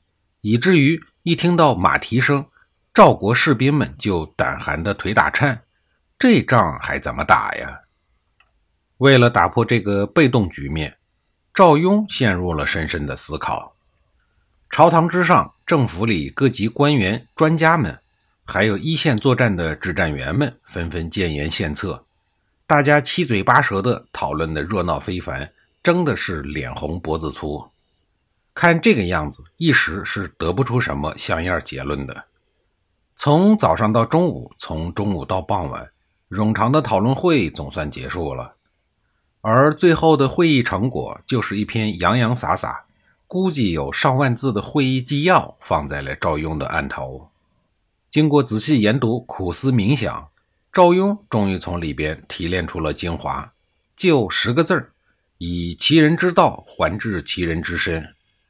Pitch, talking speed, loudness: 110 Hz, 220 characters per minute, -18 LUFS